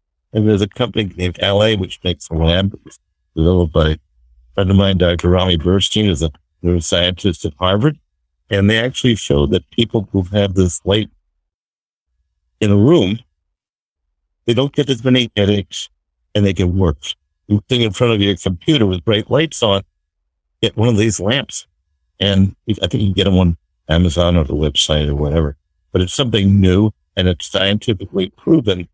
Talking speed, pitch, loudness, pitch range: 180 wpm, 95 Hz, -16 LUFS, 80-105 Hz